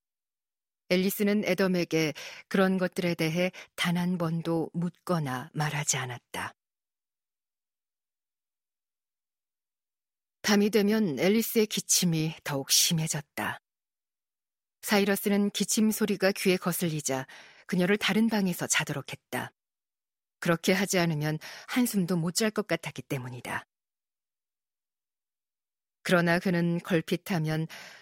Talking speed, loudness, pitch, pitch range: 225 characters per minute, -28 LUFS, 180 Hz, 160-200 Hz